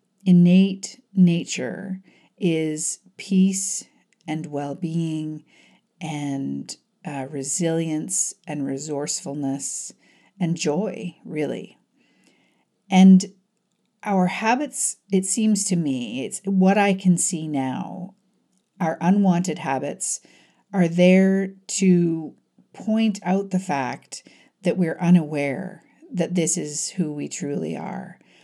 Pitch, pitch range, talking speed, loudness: 180 Hz, 155-195 Hz, 100 wpm, -22 LUFS